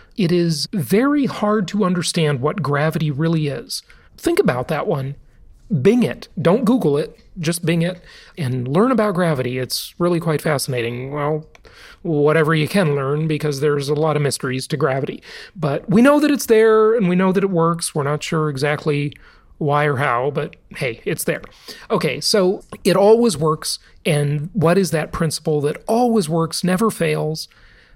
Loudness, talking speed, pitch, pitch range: -19 LUFS, 175 wpm, 165 Hz, 150-195 Hz